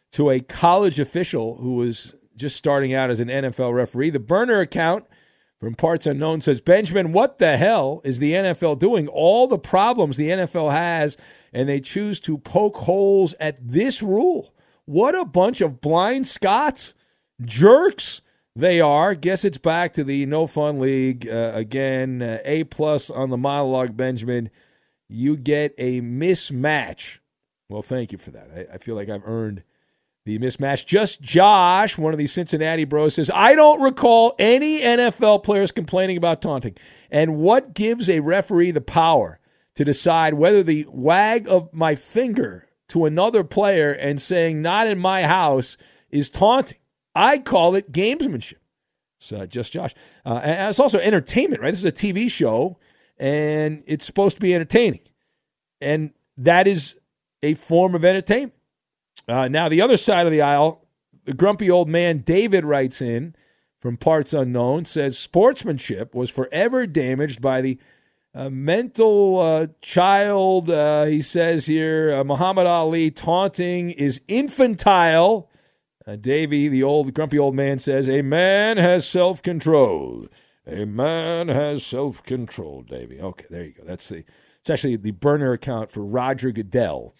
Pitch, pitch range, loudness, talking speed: 155 Hz, 135-185 Hz, -19 LUFS, 160 wpm